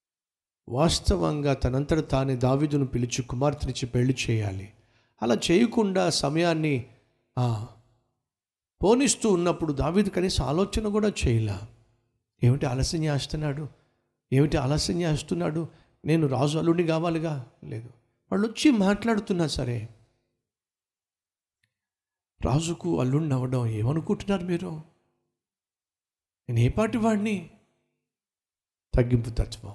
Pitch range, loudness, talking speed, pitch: 115-165 Hz, -26 LUFS, 85 wpm, 135 Hz